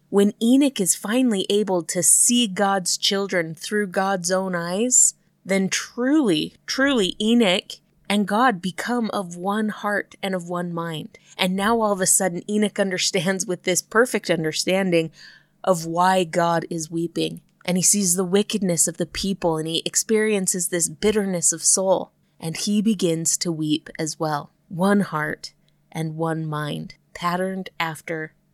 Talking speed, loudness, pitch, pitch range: 155 wpm, -21 LUFS, 185 Hz, 170-205 Hz